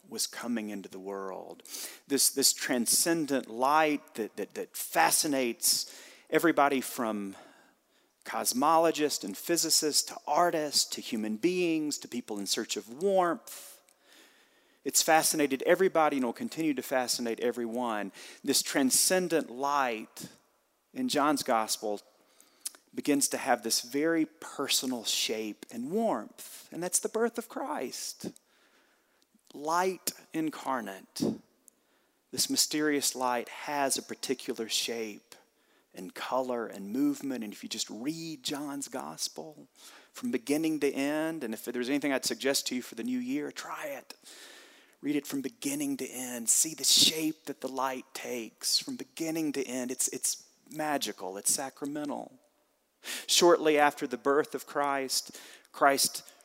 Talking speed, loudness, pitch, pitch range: 135 wpm, -29 LUFS, 145 Hz, 125-160 Hz